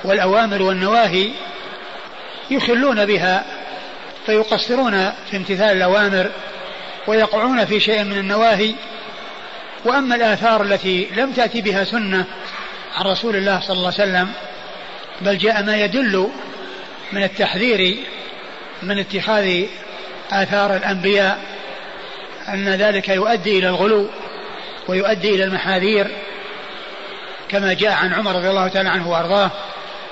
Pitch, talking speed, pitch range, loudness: 200 Hz, 110 wpm, 190-215 Hz, -17 LUFS